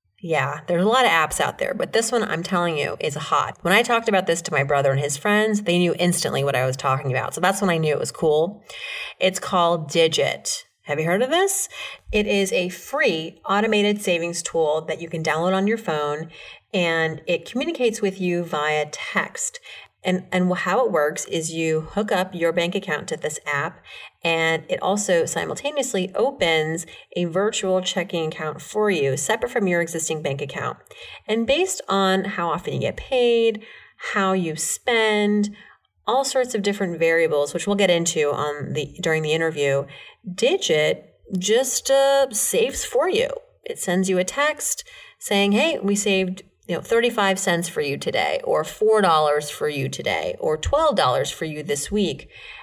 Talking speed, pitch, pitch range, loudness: 185 wpm, 185 Hz, 160-220 Hz, -22 LUFS